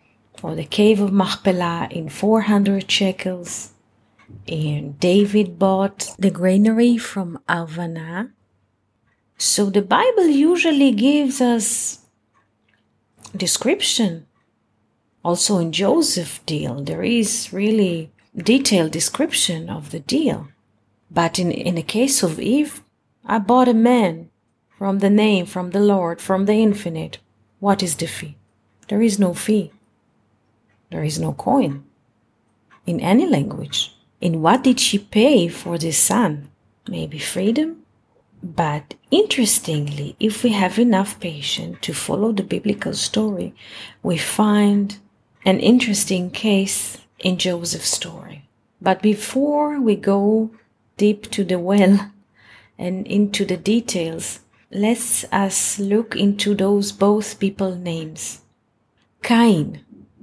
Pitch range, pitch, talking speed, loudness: 165-215 Hz, 195 Hz, 120 wpm, -19 LUFS